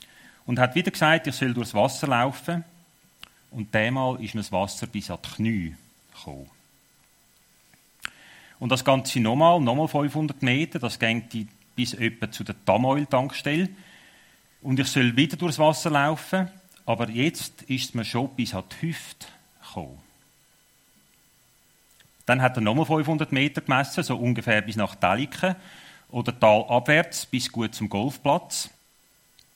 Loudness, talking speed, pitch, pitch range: -24 LUFS, 140 wpm, 130 Hz, 115-155 Hz